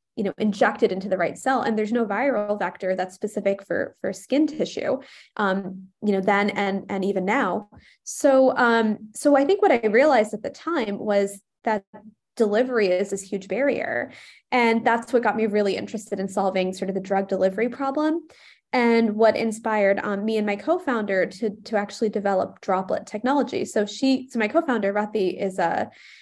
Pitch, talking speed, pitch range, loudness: 215 Hz, 185 wpm, 195-240 Hz, -23 LUFS